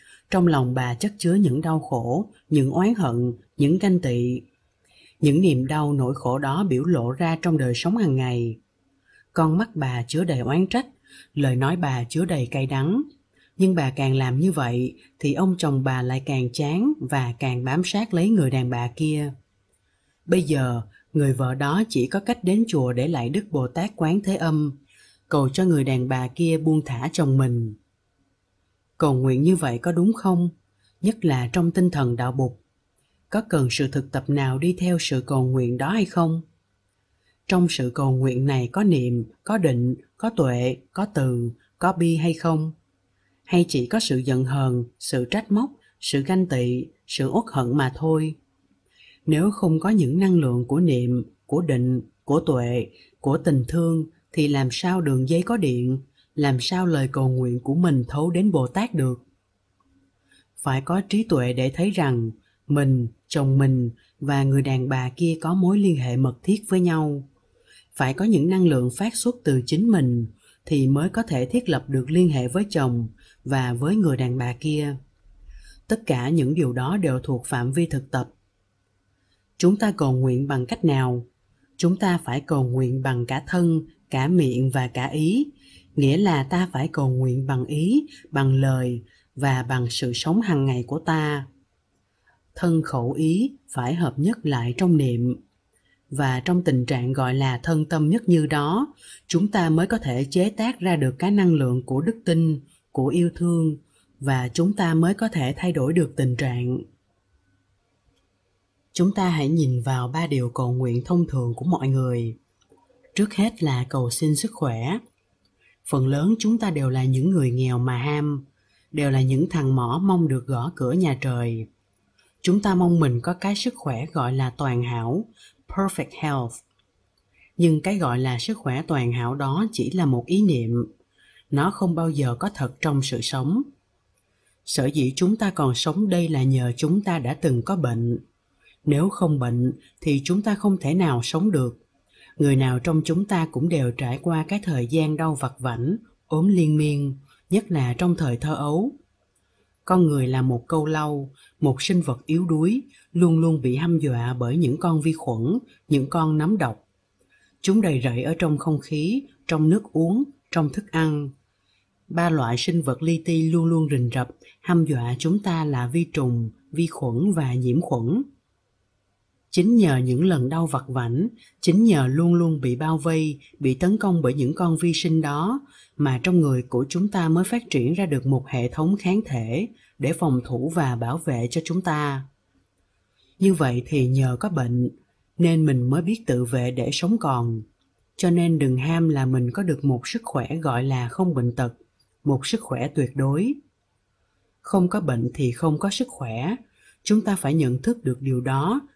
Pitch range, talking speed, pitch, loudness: 125-170 Hz, 190 wpm, 140 Hz, -23 LUFS